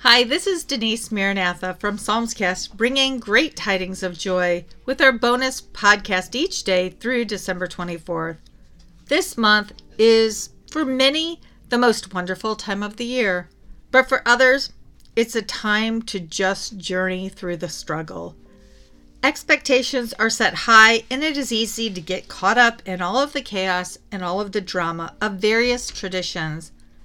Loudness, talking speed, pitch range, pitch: -20 LUFS, 155 wpm, 185-245 Hz, 210 Hz